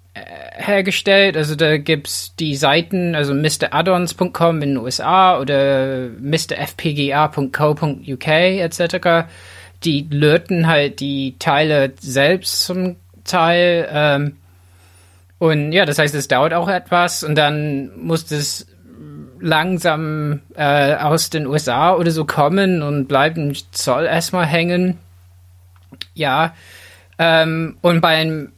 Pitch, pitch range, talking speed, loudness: 150 Hz, 135-170 Hz, 105 wpm, -16 LUFS